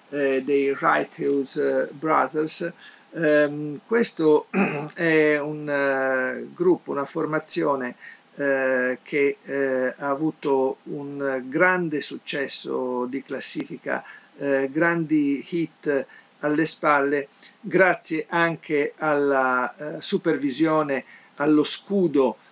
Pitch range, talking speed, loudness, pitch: 140-160 Hz, 95 wpm, -23 LUFS, 150 Hz